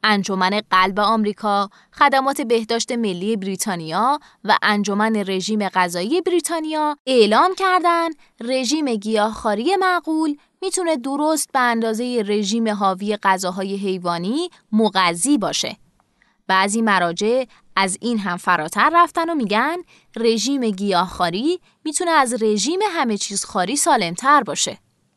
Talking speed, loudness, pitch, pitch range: 110 wpm, -19 LUFS, 225 Hz, 200-290 Hz